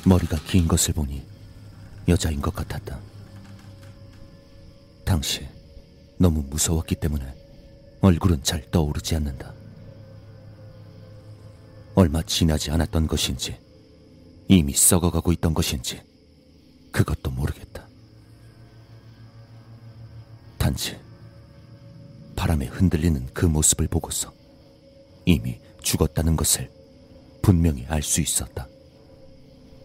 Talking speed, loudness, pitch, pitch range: 195 characters per minute, -23 LUFS, 95 Hz, 80-110 Hz